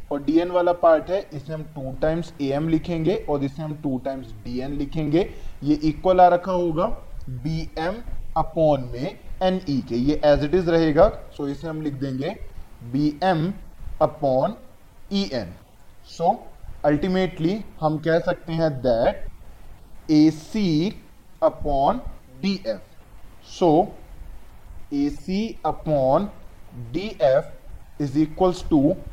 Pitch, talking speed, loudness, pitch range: 155 Hz, 145 wpm, -23 LUFS, 145-175 Hz